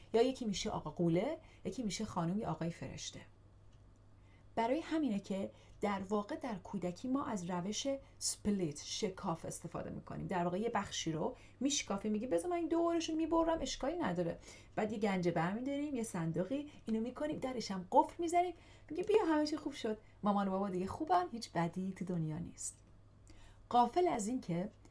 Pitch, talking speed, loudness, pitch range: 210 Hz, 170 wpm, -38 LUFS, 175-275 Hz